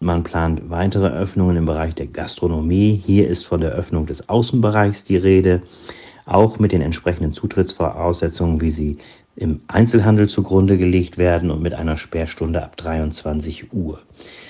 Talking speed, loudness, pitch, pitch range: 150 wpm, -18 LUFS, 85 Hz, 80-95 Hz